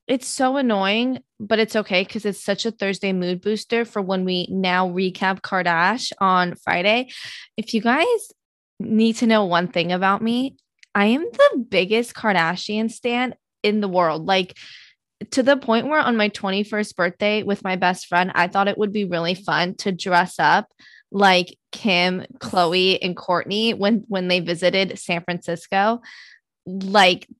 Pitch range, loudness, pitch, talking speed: 180-225 Hz, -20 LUFS, 200 Hz, 165 wpm